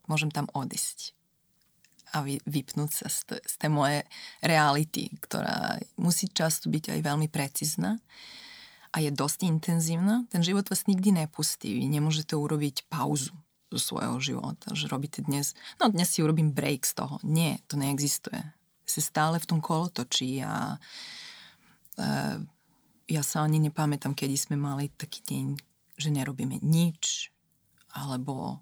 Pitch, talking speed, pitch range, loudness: 155 Hz, 140 wpm, 145-170 Hz, -29 LUFS